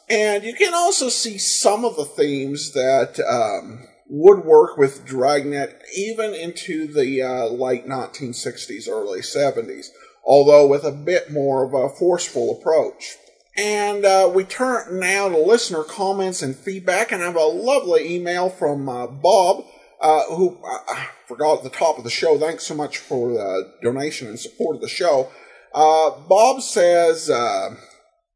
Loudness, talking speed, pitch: -19 LUFS, 165 wpm, 185 Hz